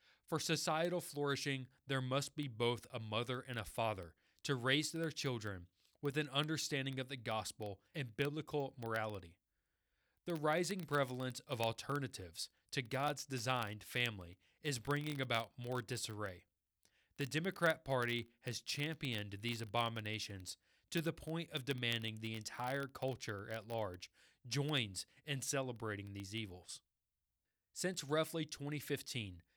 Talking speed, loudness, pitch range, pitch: 130 wpm, -41 LUFS, 105-145 Hz, 125 Hz